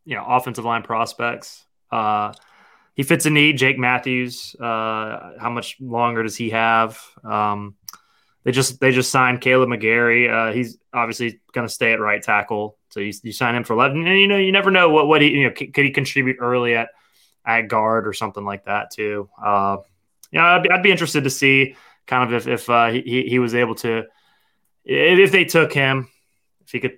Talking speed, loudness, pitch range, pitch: 210 wpm, -18 LUFS, 115-135 Hz, 120 Hz